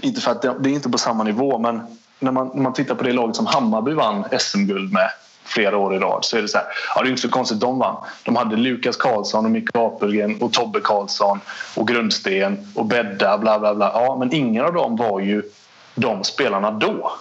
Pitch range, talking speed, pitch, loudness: 110-135 Hz, 235 wpm, 125 Hz, -20 LUFS